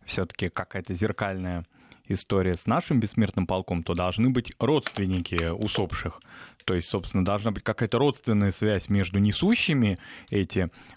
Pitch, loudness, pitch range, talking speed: 100 Hz, -27 LUFS, 90-115 Hz, 130 wpm